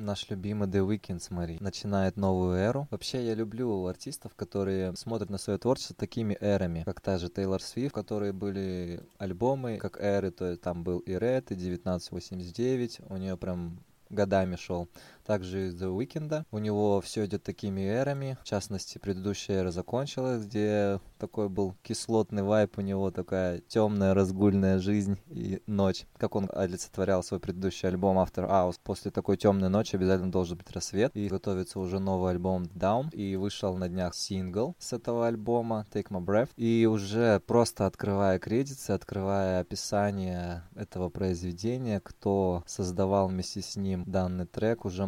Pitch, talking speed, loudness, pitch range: 100 Hz, 160 wpm, -31 LUFS, 95-105 Hz